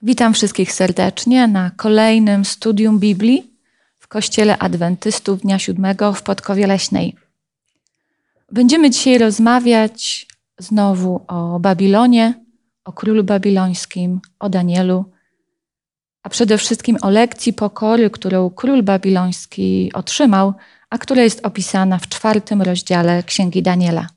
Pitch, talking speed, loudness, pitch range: 205 Hz, 110 wpm, -15 LUFS, 185-230 Hz